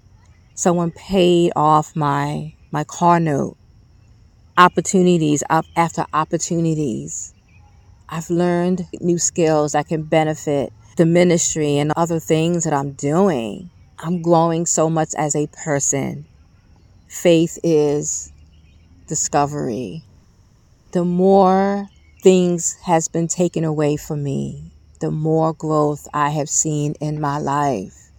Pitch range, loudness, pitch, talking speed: 115-170 Hz, -18 LUFS, 155 Hz, 115 wpm